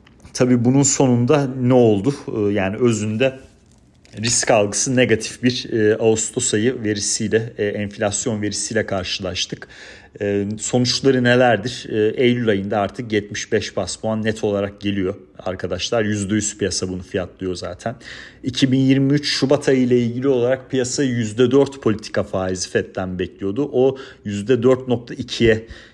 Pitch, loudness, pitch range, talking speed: 110 Hz, -19 LUFS, 100-130 Hz, 110 wpm